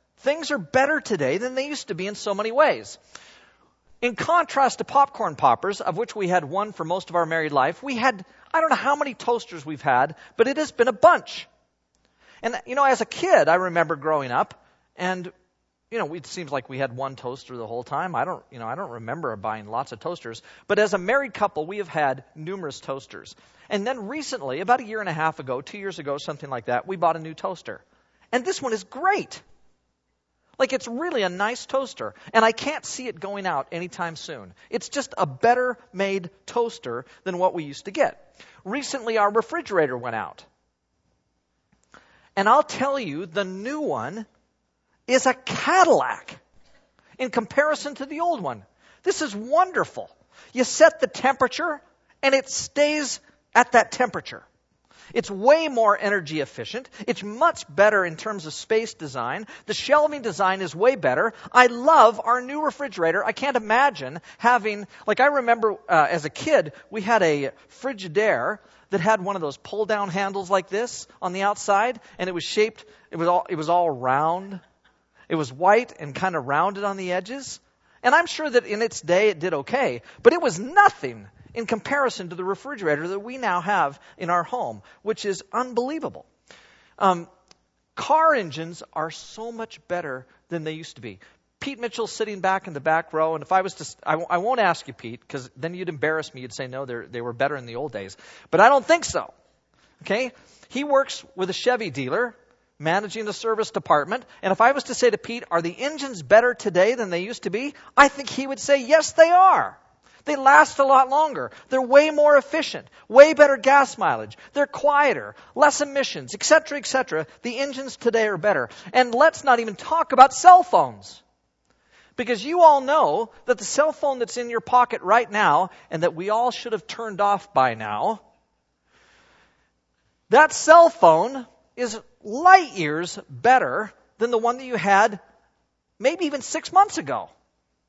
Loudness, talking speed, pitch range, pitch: -22 LUFS, 195 wpm, 170-270 Hz, 215 Hz